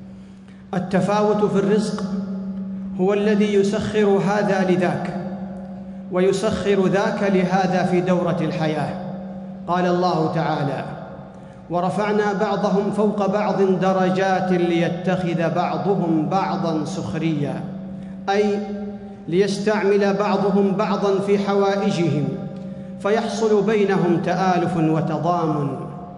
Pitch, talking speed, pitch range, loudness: 190 Hz, 85 wpm, 180-200 Hz, -20 LUFS